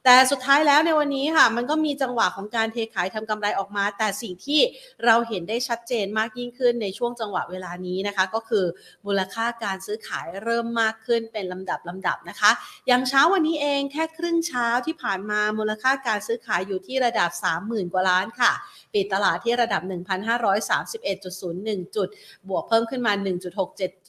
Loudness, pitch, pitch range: -24 LUFS, 225 Hz, 195-250 Hz